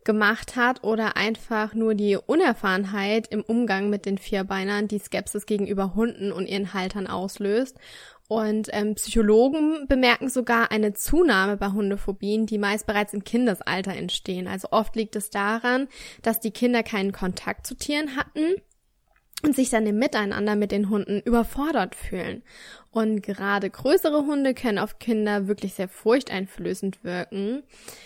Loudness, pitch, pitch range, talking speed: -24 LUFS, 215 Hz, 200-235 Hz, 150 wpm